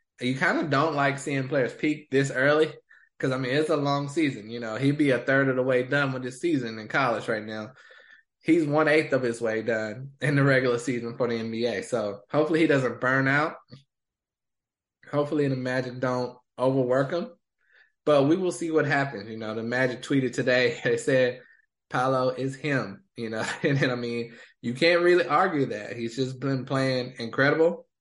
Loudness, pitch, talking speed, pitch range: -25 LUFS, 130 Hz, 200 wpm, 120-145 Hz